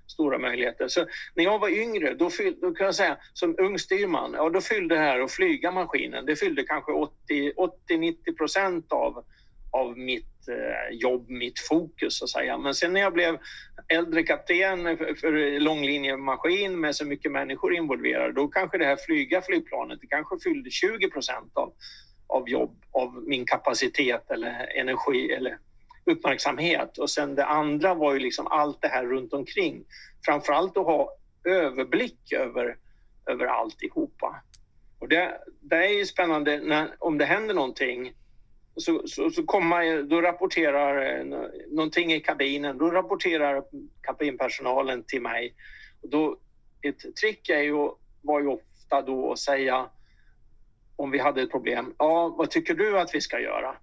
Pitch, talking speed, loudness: 165 Hz, 160 wpm, -26 LUFS